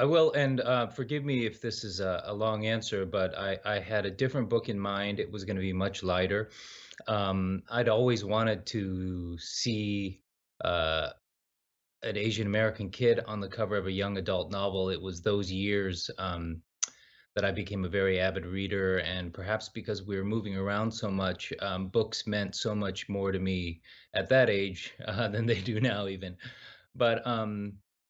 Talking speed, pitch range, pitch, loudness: 190 wpm, 95-110 Hz, 100 Hz, -31 LUFS